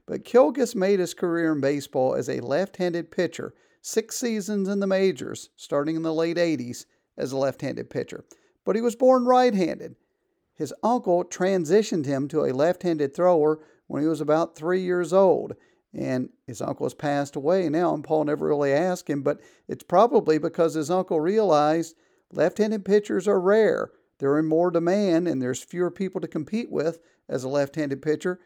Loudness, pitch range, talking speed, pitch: -24 LUFS, 150-195 Hz, 175 wpm, 170 Hz